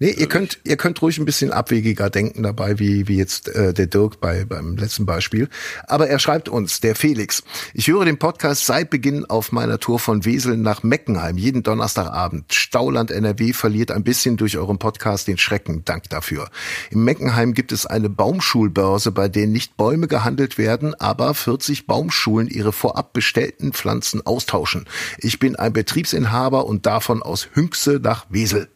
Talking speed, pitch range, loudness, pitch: 175 wpm, 105-135 Hz, -19 LUFS, 115 Hz